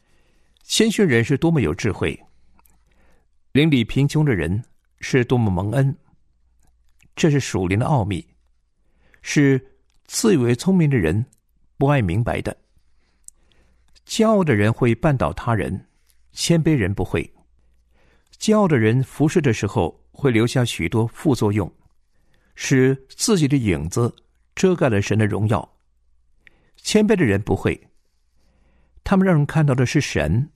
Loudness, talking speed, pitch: -20 LUFS, 195 characters per minute, 110 Hz